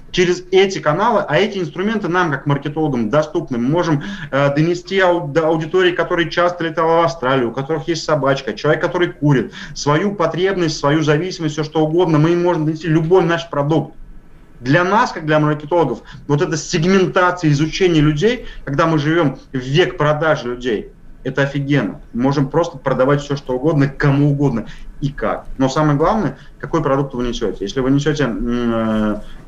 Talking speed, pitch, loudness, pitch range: 170 wpm, 155 Hz, -17 LUFS, 140-175 Hz